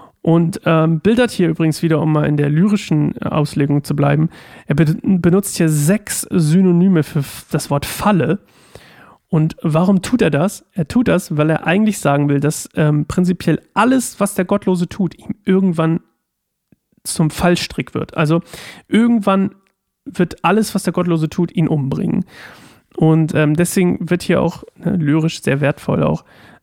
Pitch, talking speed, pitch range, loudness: 170 Hz, 160 wpm, 155-195 Hz, -16 LUFS